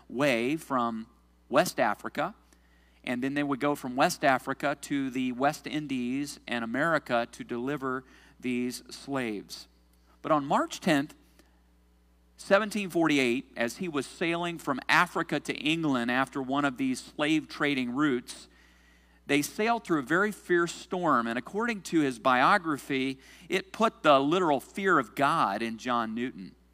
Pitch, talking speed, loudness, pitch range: 135 Hz, 145 wpm, -28 LUFS, 115-150 Hz